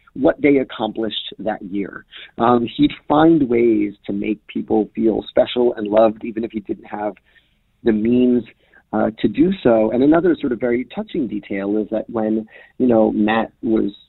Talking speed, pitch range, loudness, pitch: 175 wpm, 105-125 Hz, -18 LUFS, 115 Hz